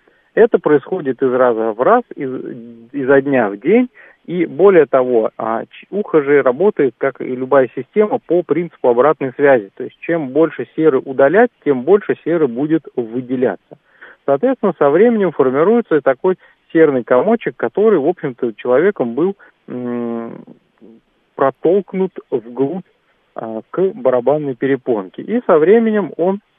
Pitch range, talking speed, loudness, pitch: 130-200 Hz, 130 wpm, -15 LUFS, 150 Hz